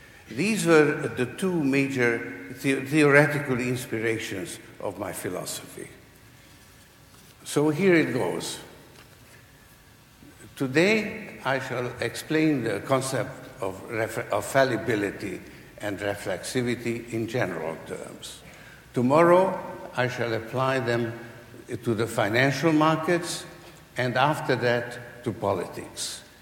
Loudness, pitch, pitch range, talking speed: -25 LUFS, 125 Hz, 115-150 Hz, 100 wpm